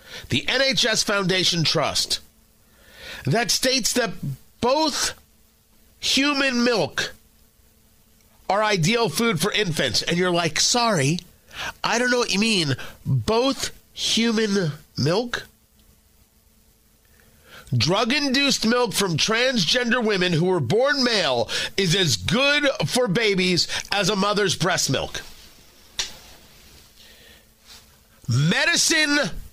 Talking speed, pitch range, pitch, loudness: 100 wpm, 155-245 Hz, 200 Hz, -21 LUFS